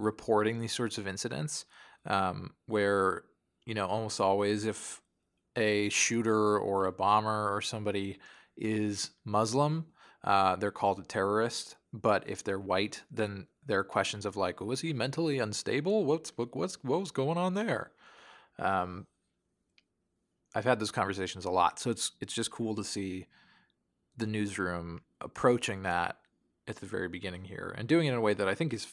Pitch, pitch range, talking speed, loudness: 105 Hz, 95-120 Hz, 170 wpm, -32 LUFS